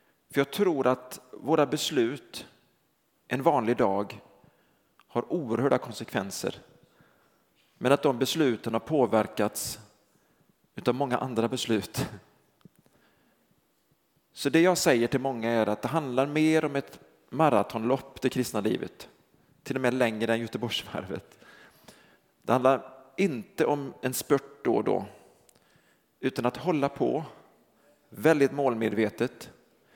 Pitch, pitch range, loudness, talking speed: 130 Hz, 115-140 Hz, -28 LUFS, 120 wpm